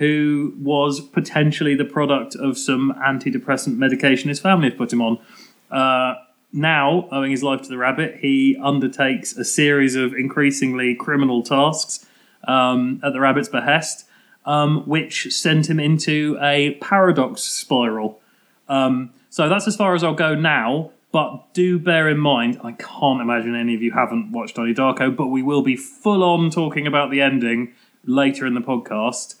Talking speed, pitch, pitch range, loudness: 165 wpm, 140 Hz, 130-150 Hz, -19 LUFS